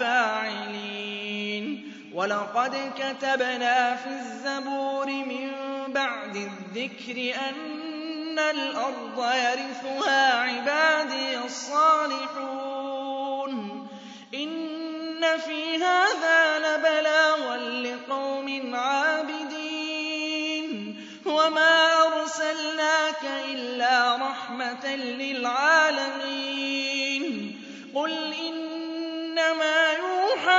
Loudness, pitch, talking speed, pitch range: -25 LUFS, 275 Hz, 50 wpm, 255-315 Hz